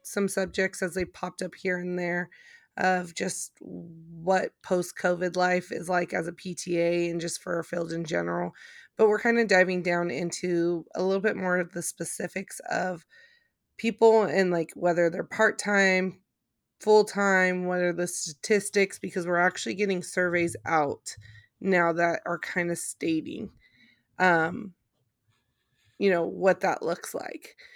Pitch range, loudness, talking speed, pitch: 170-195 Hz, -27 LUFS, 160 wpm, 180 Hz